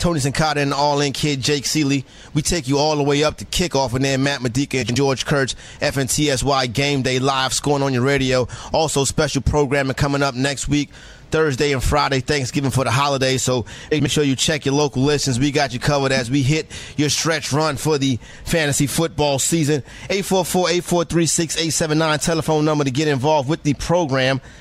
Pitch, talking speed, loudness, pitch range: 145 Hz, 195 wpm, -19 LUFS, 135-155 Hz